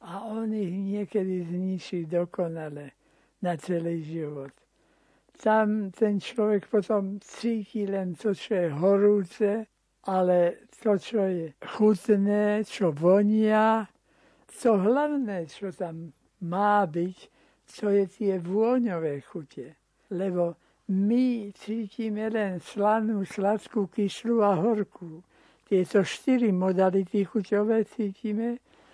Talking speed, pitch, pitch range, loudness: 105 wpm, 200 Hz, 180-215 Hz, -27 LUFS